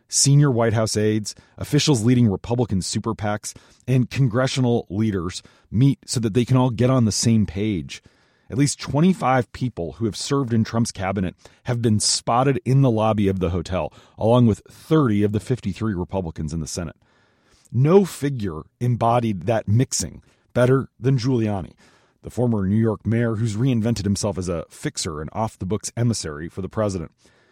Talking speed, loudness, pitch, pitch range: 170 wpm, -21 LUFS, 115 Hz, 100-125 Hz